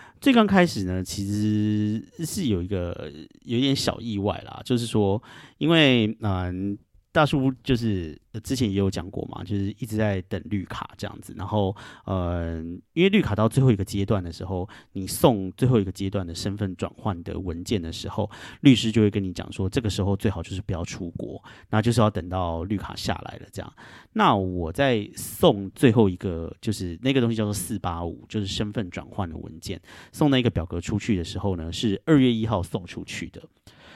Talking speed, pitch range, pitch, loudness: 285 characters per minute, 95-115 Hz, 105 Hz, -25 LUFS